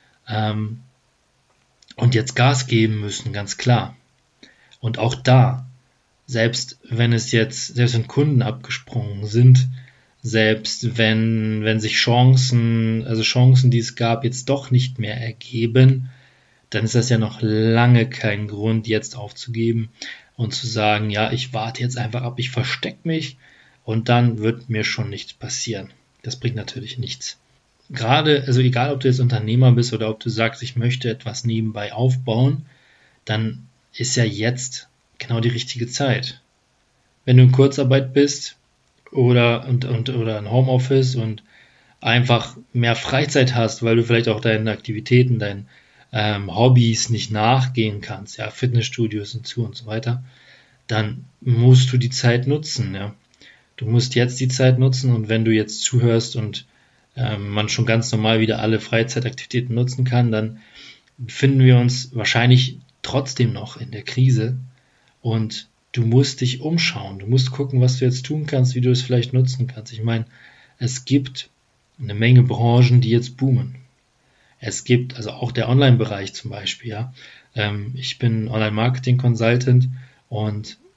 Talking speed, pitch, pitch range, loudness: 155 wpm, 120 Hz, 110-130 Hz, -19 LUFS